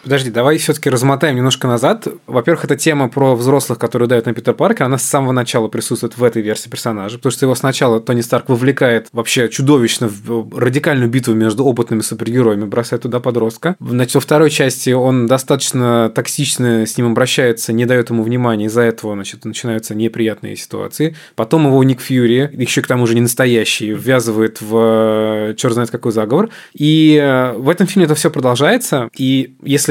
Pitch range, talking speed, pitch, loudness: 115-140 Hz, 180 wpm, 125 Hz, -14 LUFS